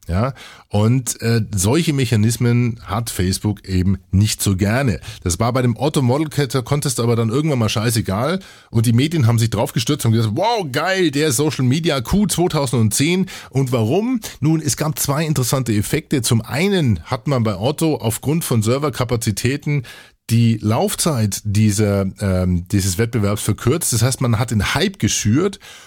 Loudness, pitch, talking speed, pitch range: -18 LUFS, 120 Hz, 160 wpm, 110-145 Hz